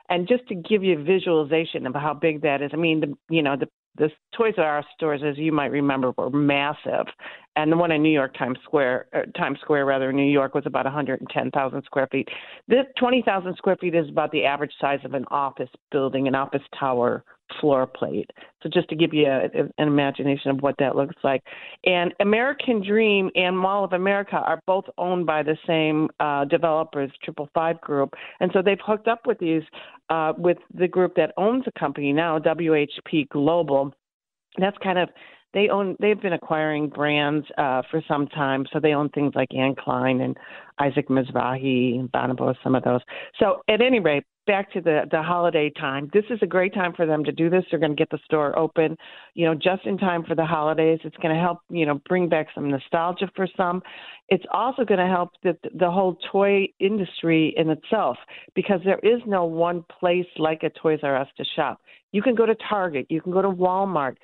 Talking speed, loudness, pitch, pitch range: 210 wpm, -23 LUFS, 160 Hz, 145-185 Hz